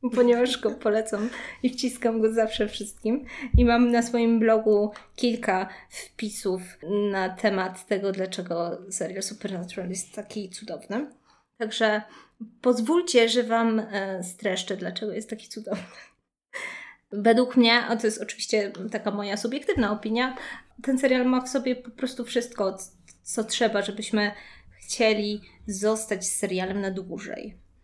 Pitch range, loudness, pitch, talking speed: 200-240 Hz, -26 LUFS, 220 Hz, 125 wpm